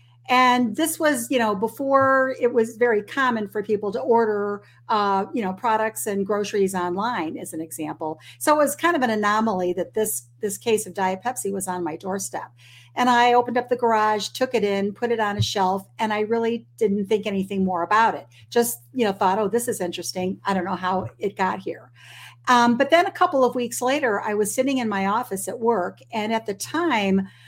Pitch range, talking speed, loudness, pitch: 185-240 Hz, 220 wpm, -22 LUFS, 210 Hz